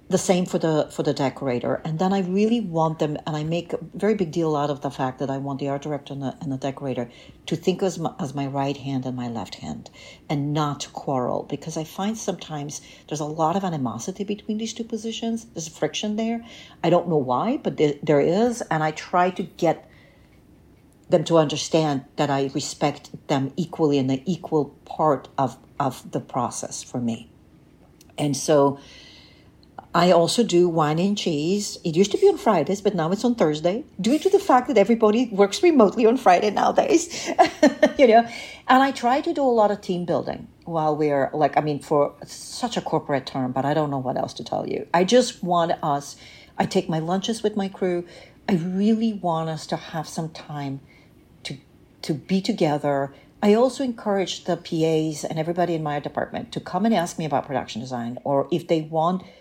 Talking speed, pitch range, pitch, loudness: 205 wpm, 145-200 Hz, 165 Hz, -23 LUFS